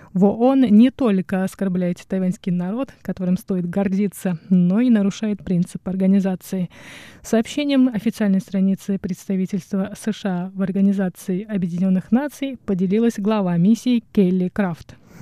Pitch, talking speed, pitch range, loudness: 195 Hz, 110 wpm, 185-215 Hz, -20 LUFS